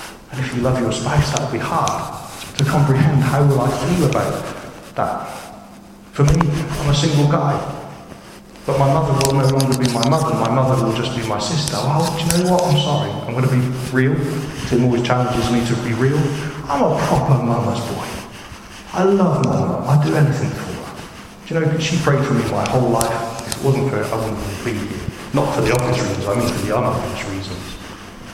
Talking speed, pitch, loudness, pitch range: 215 wpm, 135 Hz, -18 LUFS, 115-145 Hz